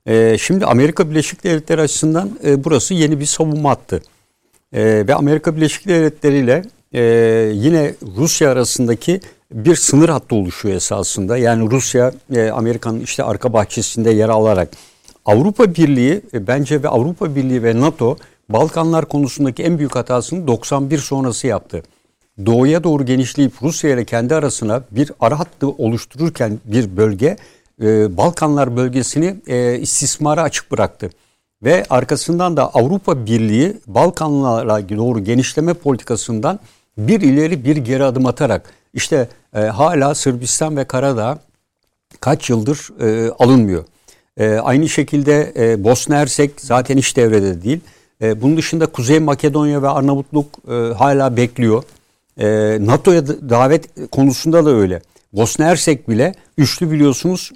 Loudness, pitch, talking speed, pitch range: -15 LUFS, 135 Hz, 125 wpm, 115-155 Hz